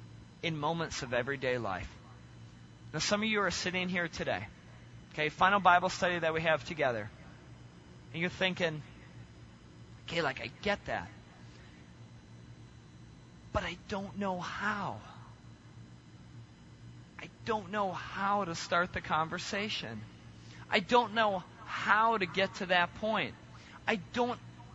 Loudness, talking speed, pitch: -33 LUFS, 130 wpm, 160 Hz